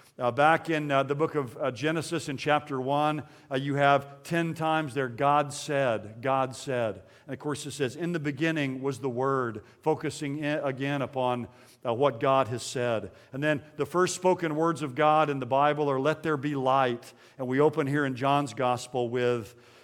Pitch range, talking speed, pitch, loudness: 130-150 Hz, 200 wpm, 140 Hz, -28 LUFS